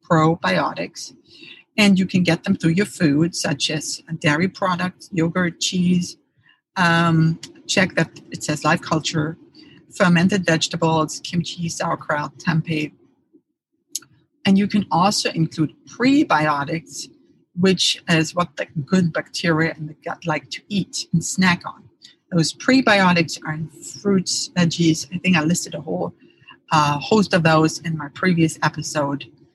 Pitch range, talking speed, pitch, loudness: 160-190 Hz, 140 wpm, 170 Hz, -20 LUFS